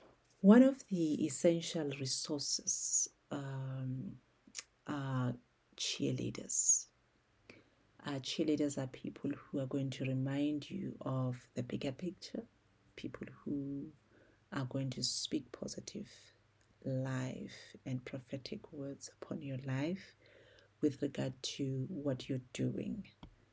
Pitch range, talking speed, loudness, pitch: 130-150 Hz, 105 wpm, -37 LUFS, 135 Hz